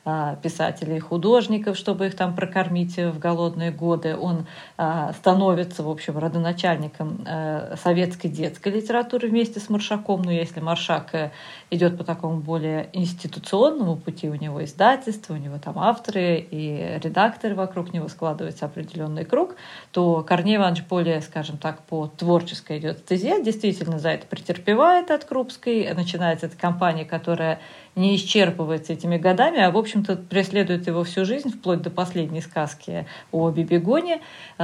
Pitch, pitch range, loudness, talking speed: 175 Hz, 160-195 Hz, -23 LUFS, 135 wpm